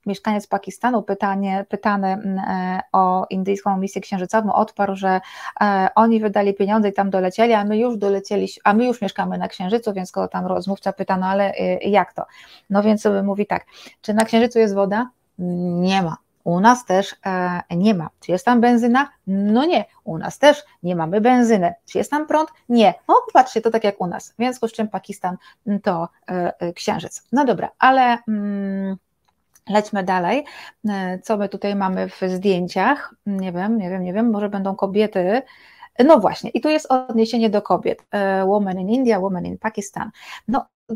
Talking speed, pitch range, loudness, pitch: 180 wpm, 190-225 Hz, -20 LUFS, 200 Hz